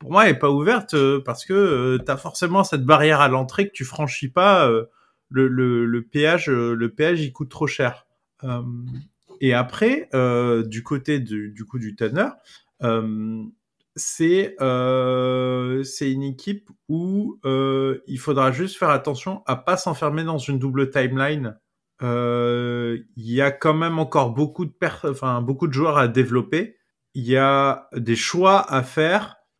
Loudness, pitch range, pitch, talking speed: -21 LUFS, 125-160 Hz, 135 Hz, 175 wpm